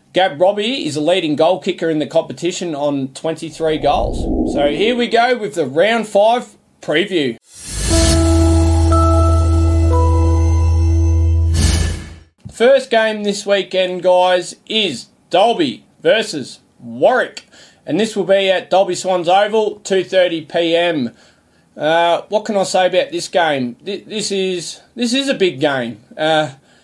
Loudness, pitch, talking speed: -16 LUFS, 170 Hz, 125 wpm